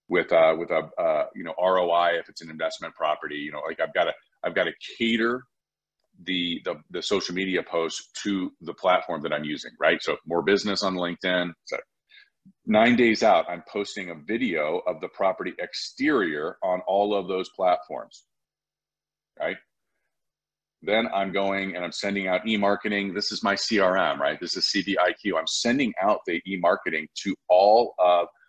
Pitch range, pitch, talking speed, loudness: 90-110 Hz, 95 Hz, 175 wpm, -25 LUFS